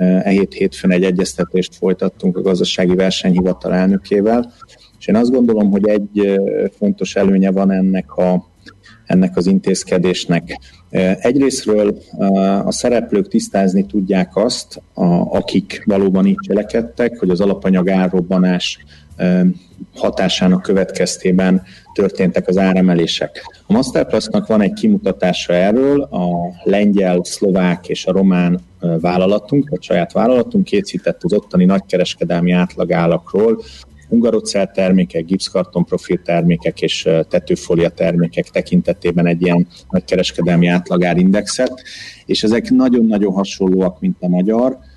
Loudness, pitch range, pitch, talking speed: -15 LUFS, 90-100 Hz, 95 Hz, 115 wpm